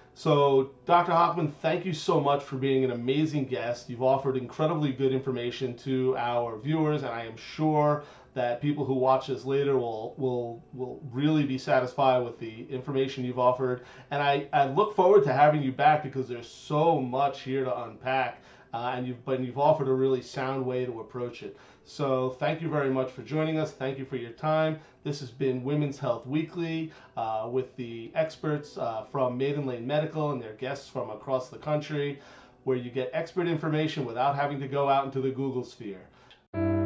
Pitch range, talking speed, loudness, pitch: 125-150 Hz, 195 wpm, -28 LUFS, 135 Hz